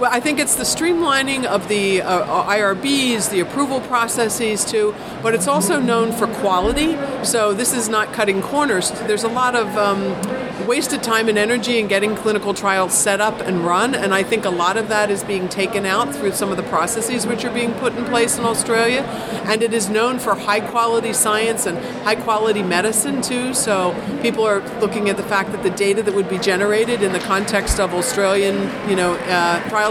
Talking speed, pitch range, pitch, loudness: 205 wpm, 200-235 Hz, 215 Hz, -18 LUFS